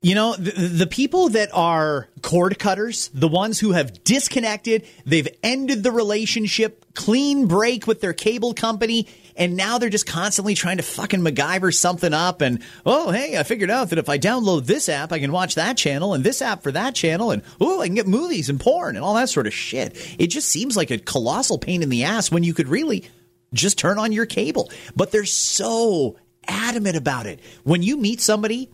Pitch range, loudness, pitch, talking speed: 165-225 Hz, -20 LUFS, 200 Hz, 210 wpm